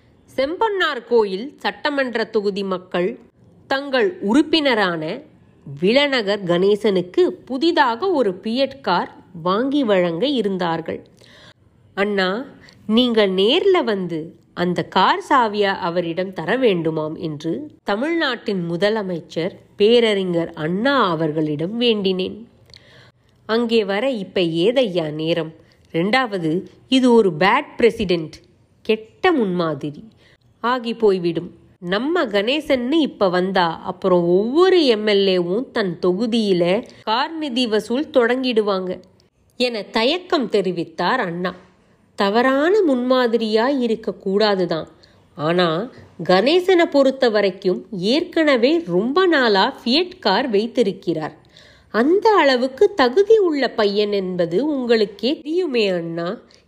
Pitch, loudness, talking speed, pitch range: 210 Hz, -19 LUFS, 90 wpm, 180-260 Hz